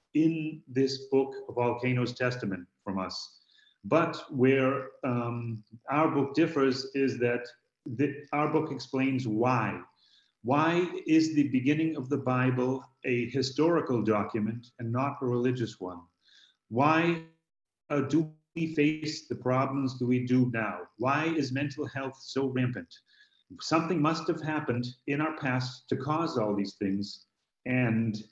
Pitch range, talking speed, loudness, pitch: 120-150 Hz, 140 wpm, -29 LUFS, 135 Hz